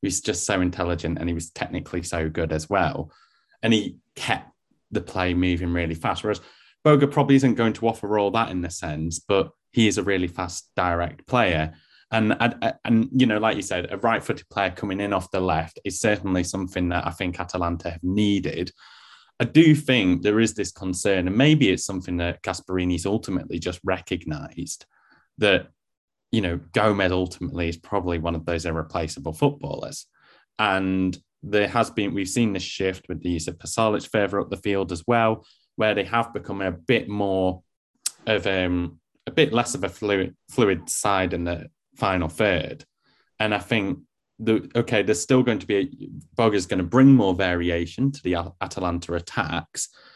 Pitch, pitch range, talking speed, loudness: 95 Hz, 85-110 Hz, 185 wpm, -24 LUFS